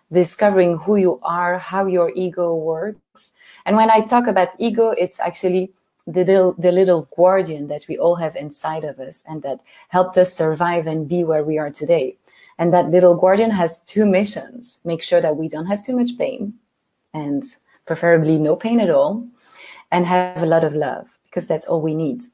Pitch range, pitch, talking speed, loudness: 165-215 Hz, 180 Hz, 195 wpm, -18 LUFS